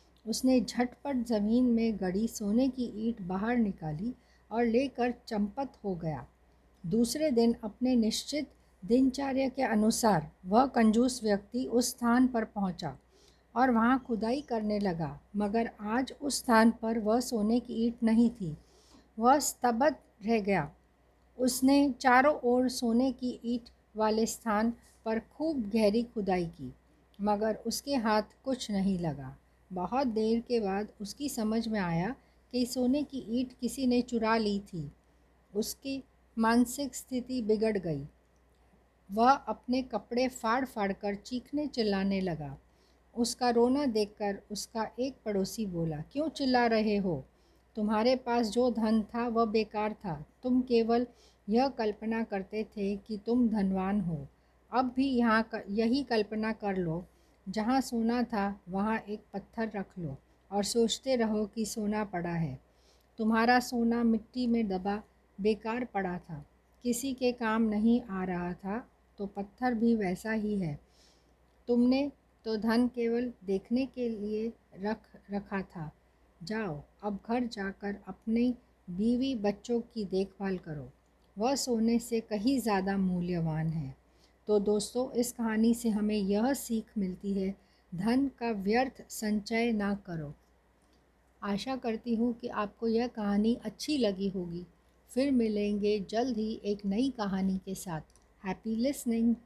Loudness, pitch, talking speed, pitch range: -31 LUFS, 220 Hz, 140 wpm, 200-240 Hz